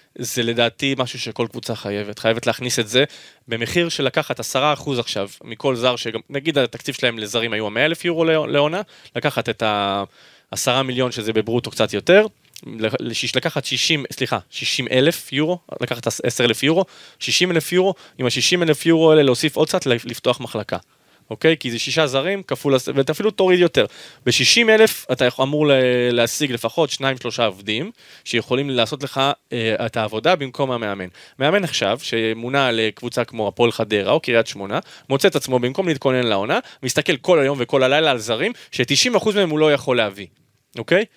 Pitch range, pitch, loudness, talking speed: 115-150 Hz, 125 Hz, -19 LUFS, 175 wpm